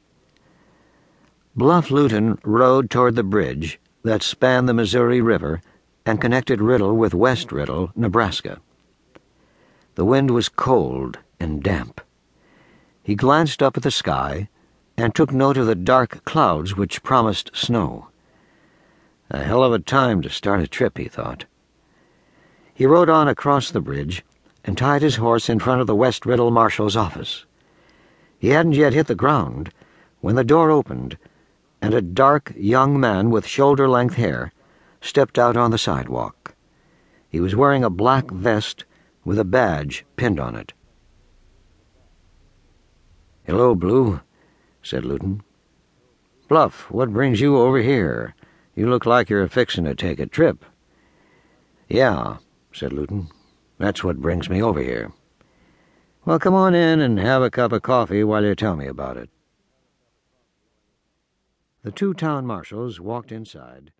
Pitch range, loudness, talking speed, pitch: 90-130 Hz, -19 LUFS, 145 wpm, 115 Hz